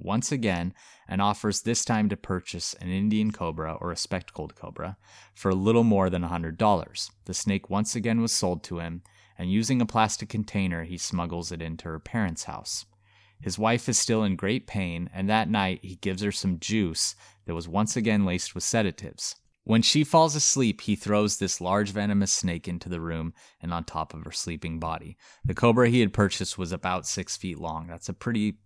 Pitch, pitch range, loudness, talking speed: 100 Hz, 90-110 Hz, -27 LUFS, 200 wpm